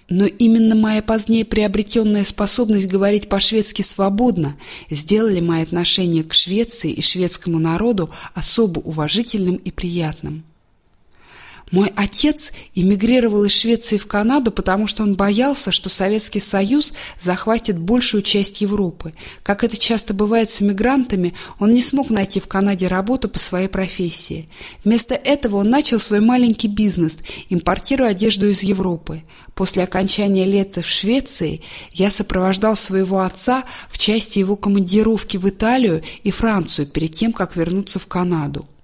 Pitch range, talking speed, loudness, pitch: 185-225 Hz, 140 wpm, -16 LUFS, 200 Hz